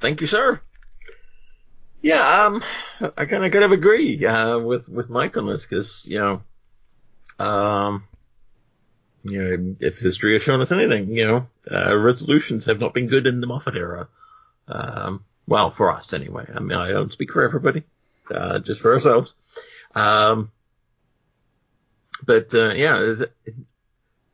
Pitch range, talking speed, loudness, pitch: 105-155 Hz, 155 wpm, -20 LUFS, 120 Hz